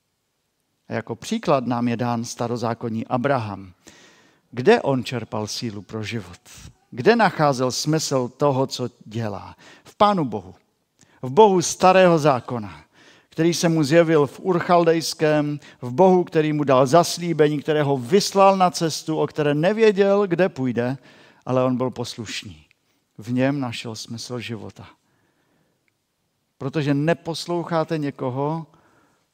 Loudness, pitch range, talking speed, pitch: -21 LUFS, 120-165 Hz, 125 wpm, 140 Hz